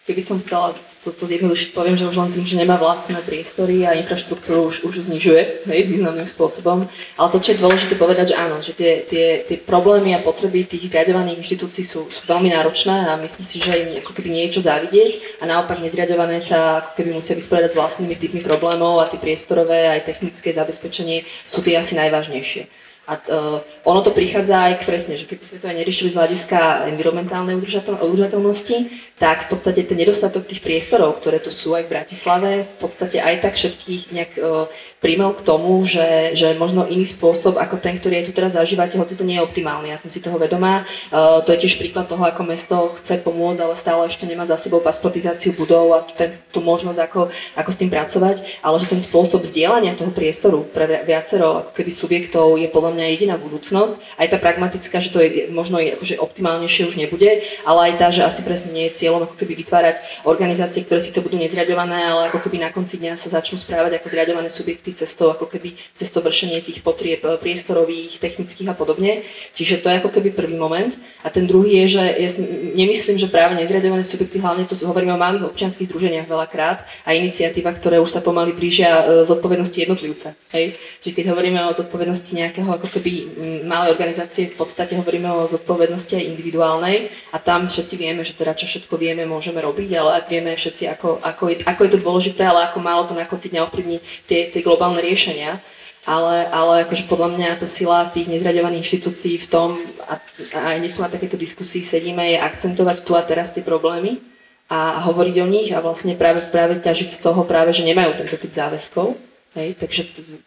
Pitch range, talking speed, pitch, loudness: 165-185 Hz, 195 wpm, 175 Hz, -18 LUFS